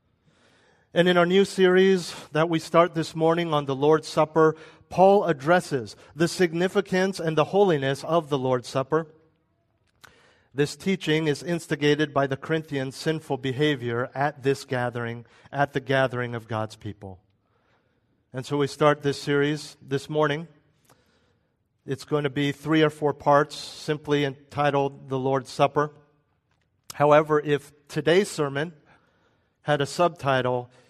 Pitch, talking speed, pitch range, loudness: 145 Hz, 140 wpm, 135-160 Hz, -24 LUFS